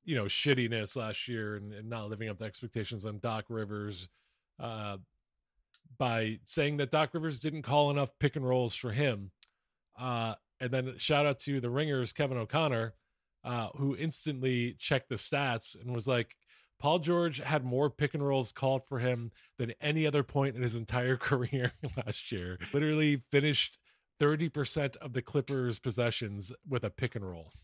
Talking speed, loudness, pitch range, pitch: 175 wpm, -33 LUFS, 115-145 Hz, 125 Hz